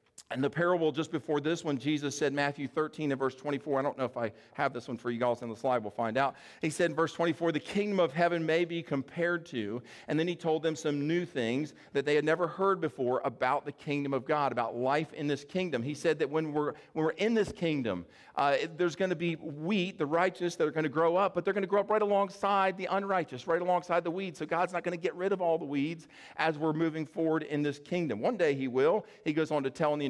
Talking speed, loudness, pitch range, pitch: 270 wpm, -31 LUFS, 140-175 Hz, 155 Hz